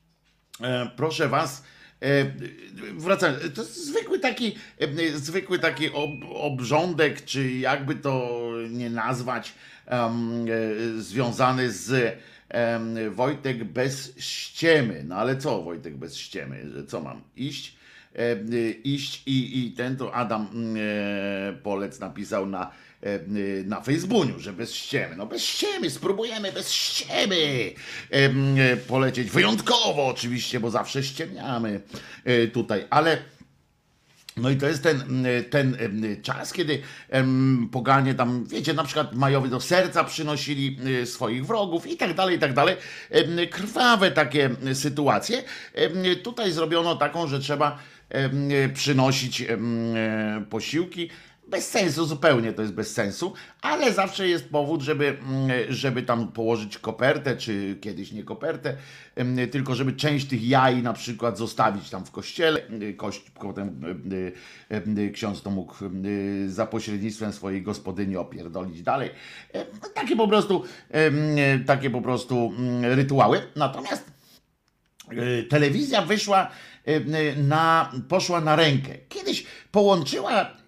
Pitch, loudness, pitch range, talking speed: 130 Hz, -25 LUFS, 115-155 Hz, 115 wpm